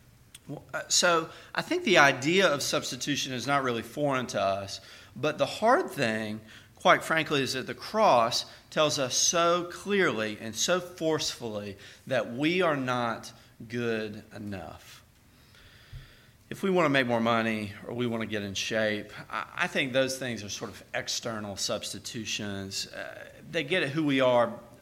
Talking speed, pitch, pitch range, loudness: 155 wpm, 120 Hz, 110-150 Hz, -28 LUFS